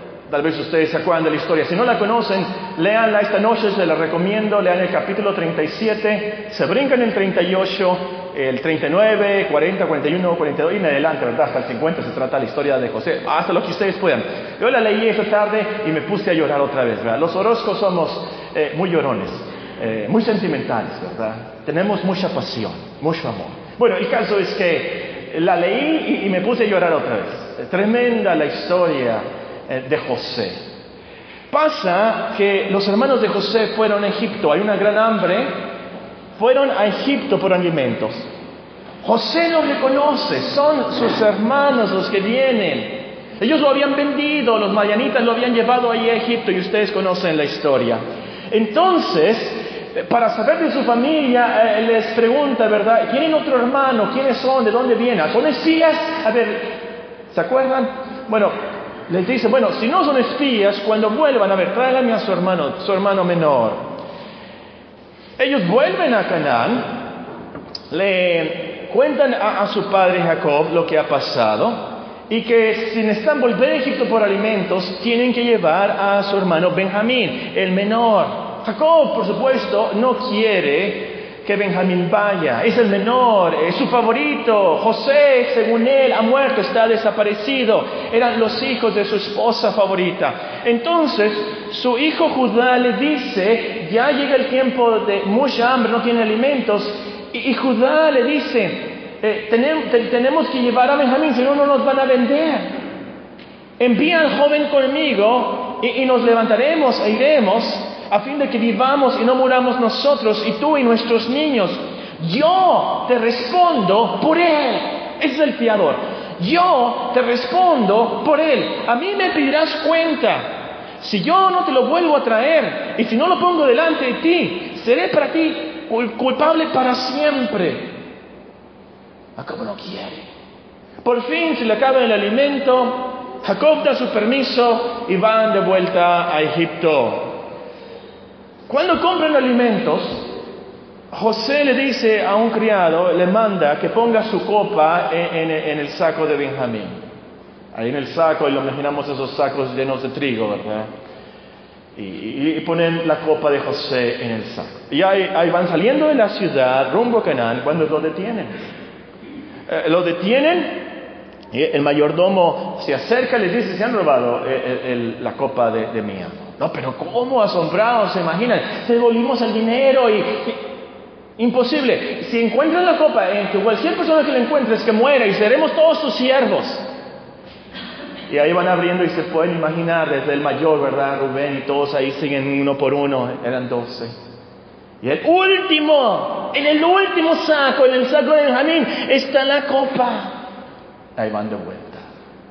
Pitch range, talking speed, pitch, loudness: 190-270 Hz, 160 wpm, 230 Hz, -17 LUFS